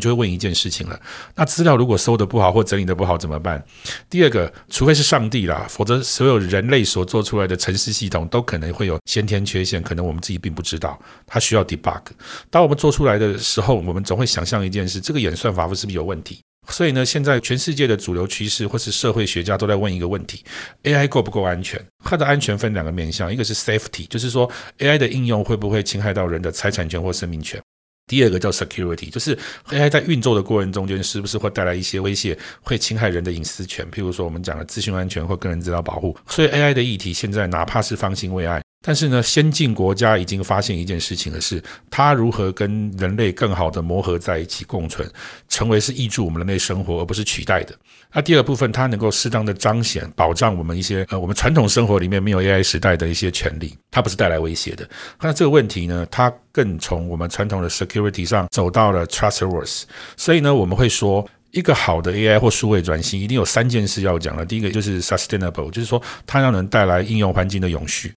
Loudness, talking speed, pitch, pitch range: -19 LUFS, 395 characters per minute, 100 Hz, 90-115 Hz